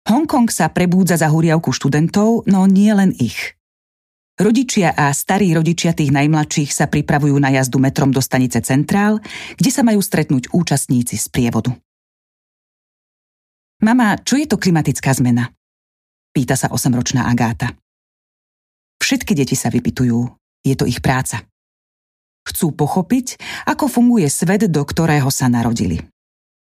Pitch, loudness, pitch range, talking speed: 150 Hz, -16 LUFS, 125-195 Hz, 130 wpm